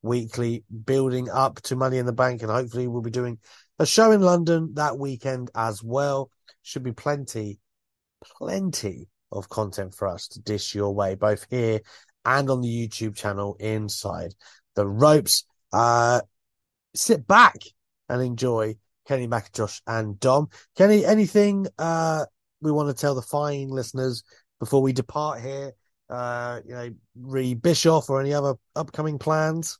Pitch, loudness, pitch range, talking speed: 125 Hz, -23 LUFS, 110-145 Hz, 155 wpm